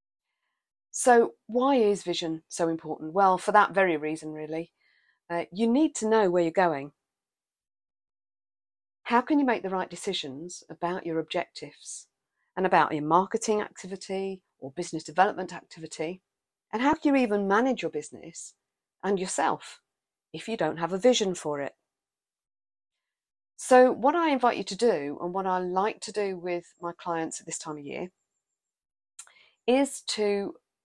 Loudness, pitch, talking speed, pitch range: -27 LUFS, 185 Hz, 155 wpm, 160-215 Hz